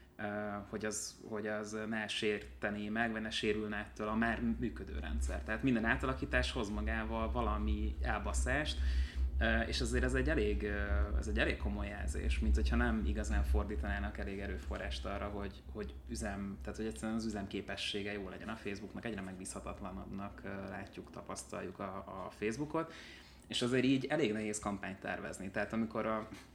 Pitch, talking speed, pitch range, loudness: 100 Hz, 155 wpm, 70-110 Hz, -38 LUFS